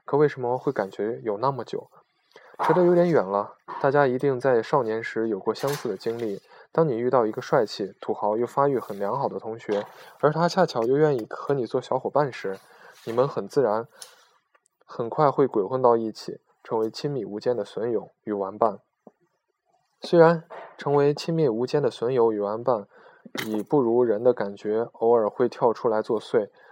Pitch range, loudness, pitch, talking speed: 110-175 Hz, -24 LUFS, 140 Hz, 265 characters per minute